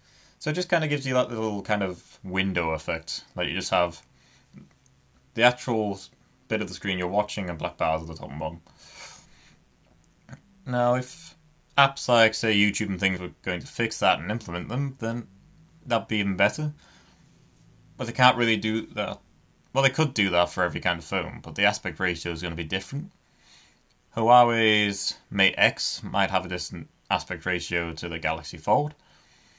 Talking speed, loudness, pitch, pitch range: 185 wpm, -25 LUFS, 105 Hz, 90-125 Hz